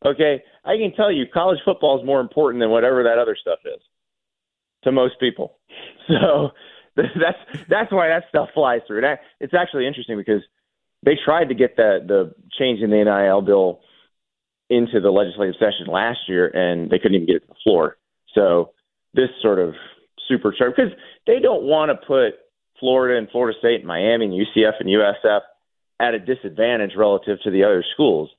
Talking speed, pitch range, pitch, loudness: 185 wpm, 105-155 Hz, 125 Hz, -19 LUFS